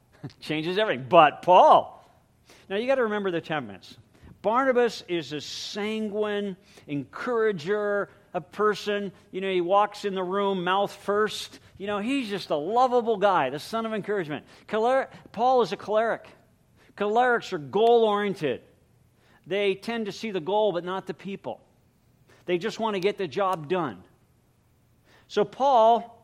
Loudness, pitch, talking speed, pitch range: -25 LUFS, 200 Hz, 150 wpm, 175-215 Hz